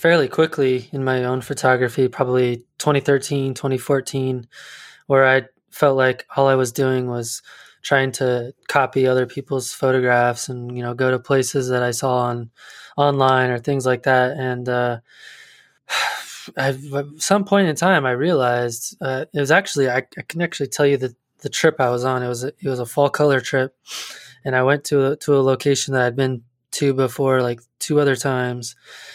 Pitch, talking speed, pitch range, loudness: 130 Hz, 190 wpm, 125-140 Hz, -19 LUFS